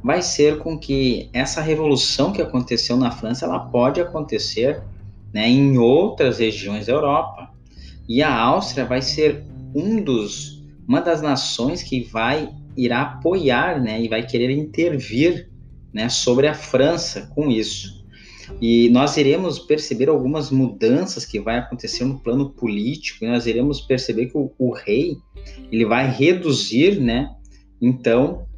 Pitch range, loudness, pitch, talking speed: 115-145 Hz, -19 LUFS, 125 Hz, 145 wpm